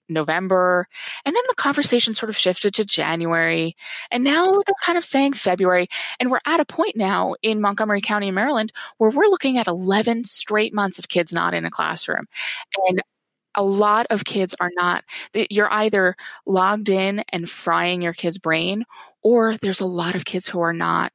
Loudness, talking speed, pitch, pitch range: -20 LUFS, 185 wpm, 200 Hz, 180-225 Hz